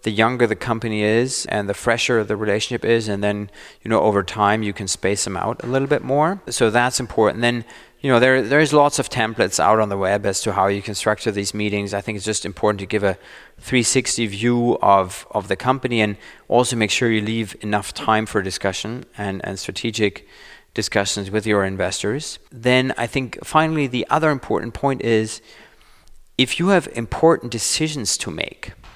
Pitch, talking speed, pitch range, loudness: 110 Hz, 200 wpm, 105-125 Hz, -20 LUFS